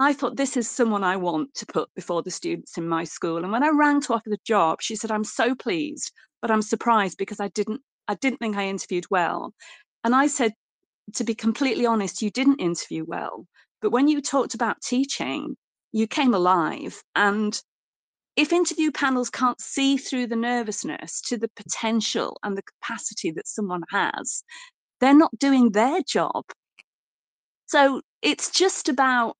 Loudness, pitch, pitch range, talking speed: -24 LUFS, 230 Hz, 210-275 Hz, 180 wpm